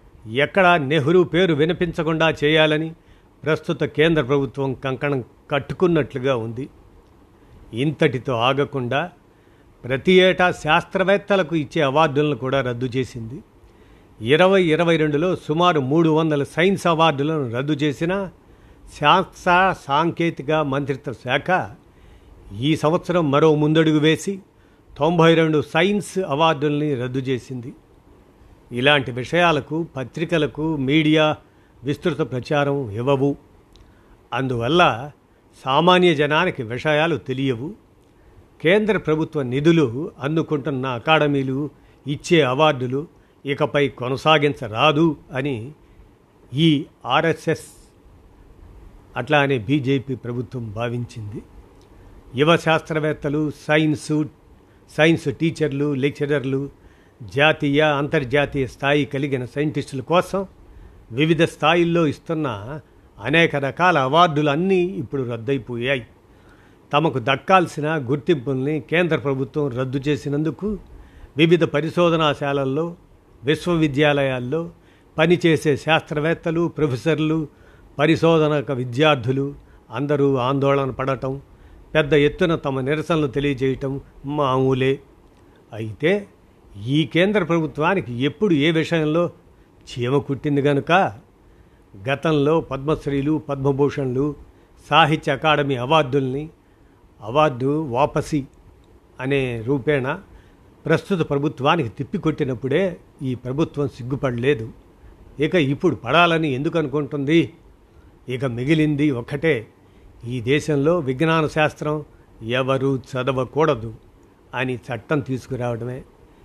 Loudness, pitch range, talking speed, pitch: -20 LUFS, 130-160 Hz, 85 wpm, 145 Hz